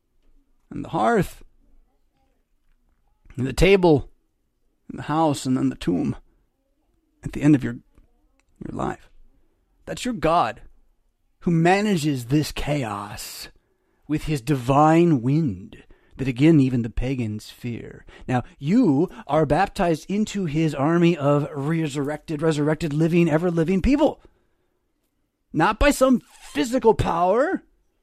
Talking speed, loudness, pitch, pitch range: 120 wpm, -22 LUFS, 155 Hz, 135-175 Hz